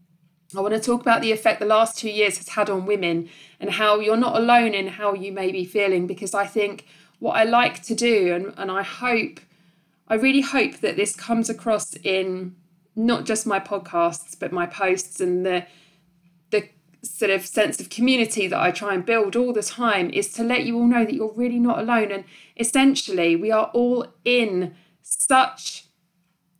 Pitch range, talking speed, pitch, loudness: 180-230 Hz, 200 wpm, 205 Hz, -22 LUFS